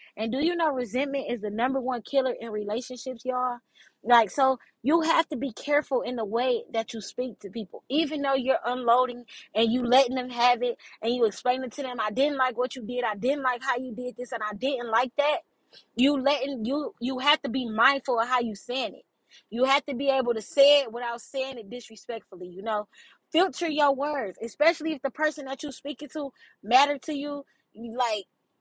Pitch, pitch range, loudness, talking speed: 255 Hz, 235-280 Hz, -26 LUFS, 220 wpm